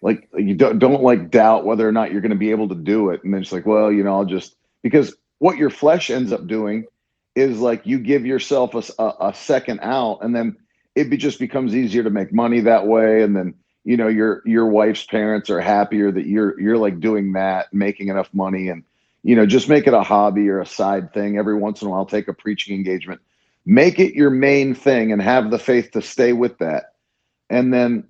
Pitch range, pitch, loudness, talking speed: 100-120 Hz, 110 Hz, -18 LUFS, 235 wpm